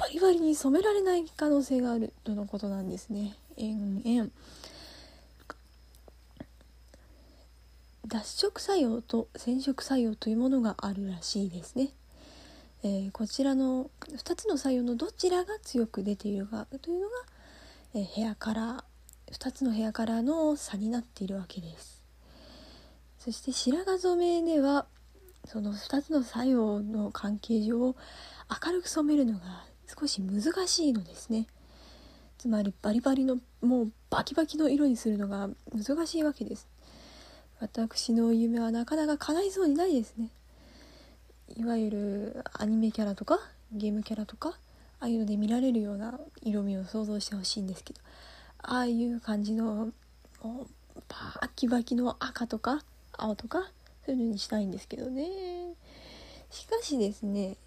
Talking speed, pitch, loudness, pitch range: 290 characters per minute, 230 Hz, -31 LUFS, 210-280 Hz